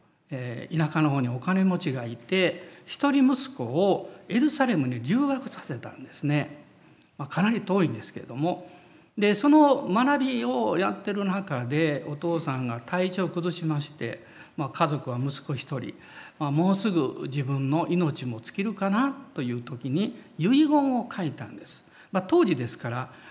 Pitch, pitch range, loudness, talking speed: 175 Hz, 145-205 Hz, -26 LUFS, 305 characters per minute